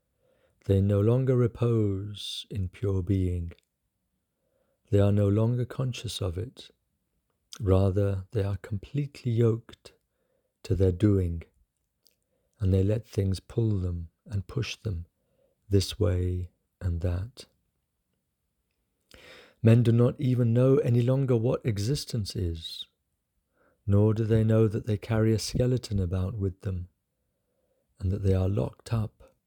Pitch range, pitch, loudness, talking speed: 95-115 Hz, 100 Hz, -27 LUFS, 130 wpm